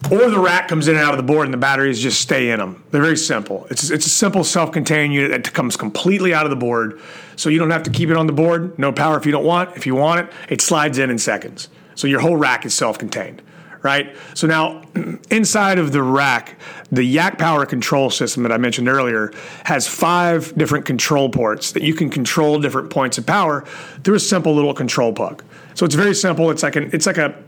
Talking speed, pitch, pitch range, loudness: 240 wpm, 155 Hz, 135-165 Hz, -17 LUFS